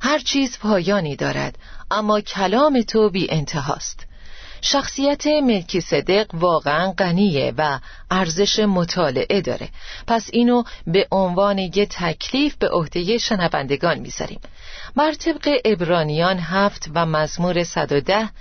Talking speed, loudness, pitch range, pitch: 115 wpm, -20 LUFS, 170-230 Hz, 195 Hz